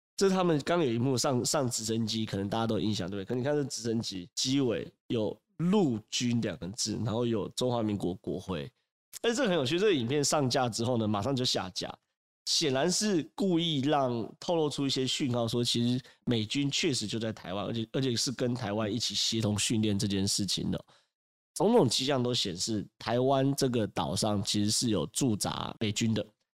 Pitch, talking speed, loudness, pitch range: 120 Hz, 305 characters per minute, -30 LUFS, 110-135 Hz